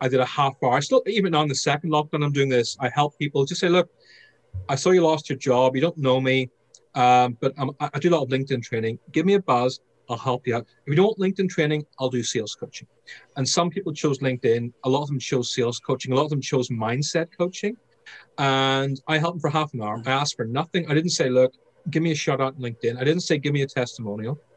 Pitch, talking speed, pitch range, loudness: 140 Hz, 265 wpm, 130-160 Hz, -23 LUFS